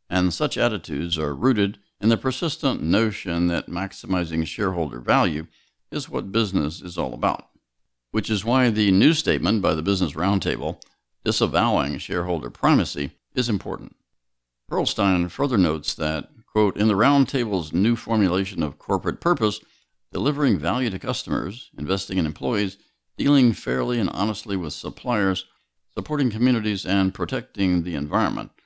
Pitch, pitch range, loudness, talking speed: 95 Hz, 85-110 Hz, -23 LUFS, 140 wpm